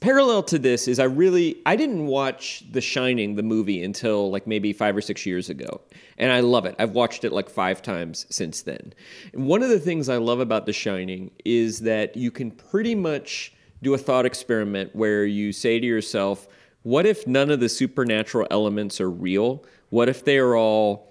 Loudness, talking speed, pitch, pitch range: -23 LUFS, 200 wpm, 115 Hz, 105-130 Hz